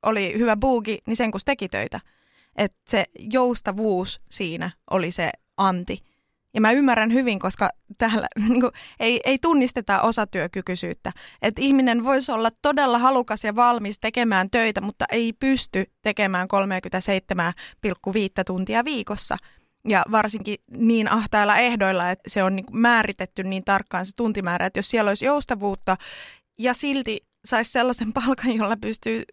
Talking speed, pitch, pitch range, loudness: 140 wpm, 220 Hz, 195-240 Hz, -22 LUFS